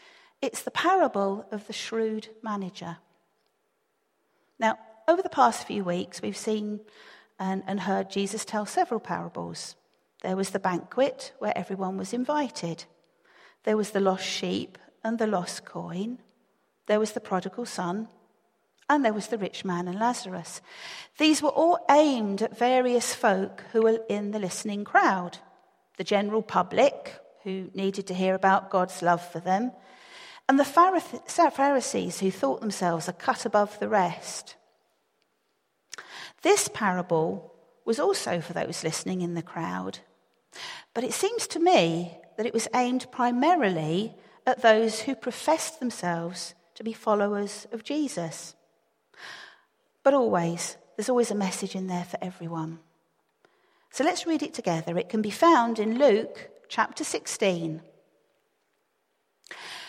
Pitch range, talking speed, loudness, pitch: 185-260 Hz, 140 wpm, -27 LUFS, 215 Hz